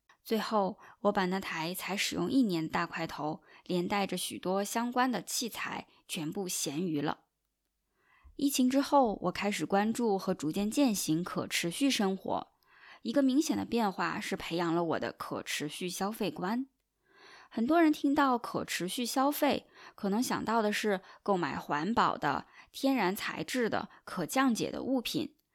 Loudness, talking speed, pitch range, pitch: -32 LUFS, 235 characters per minute, 180-265 Hz, 205 Hz